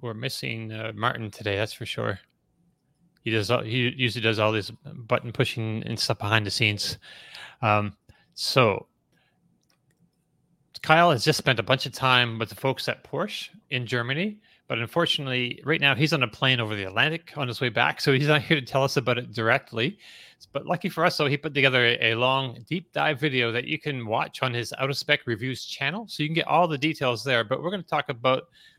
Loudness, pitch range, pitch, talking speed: -25 LUFS, 115-150 Hz, 130 Hz, 215 wpm